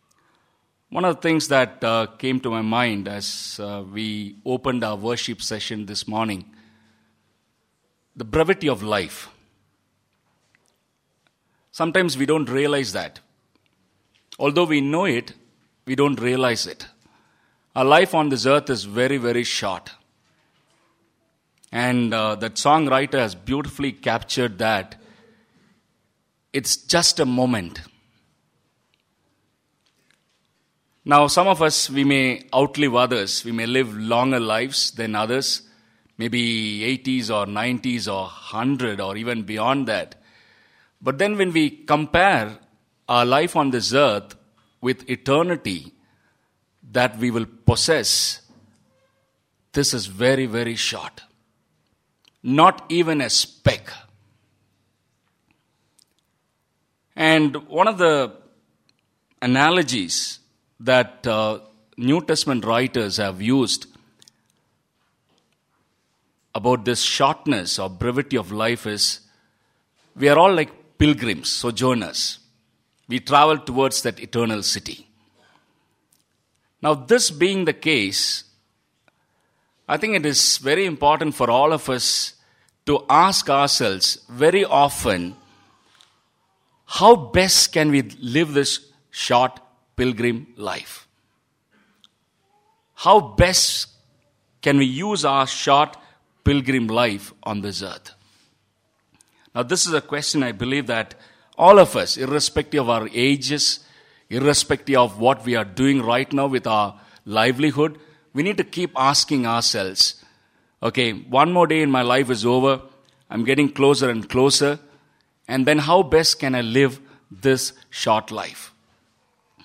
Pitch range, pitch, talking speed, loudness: 115-145 Hz, 130 Hz, 120 wpm, -20 LUFS